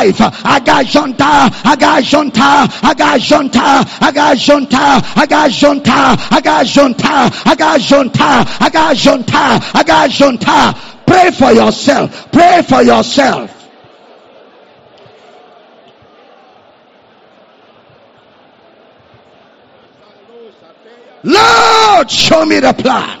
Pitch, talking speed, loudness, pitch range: 285 Hz, 75 wpm, -8 LUFS, 260-305 Hz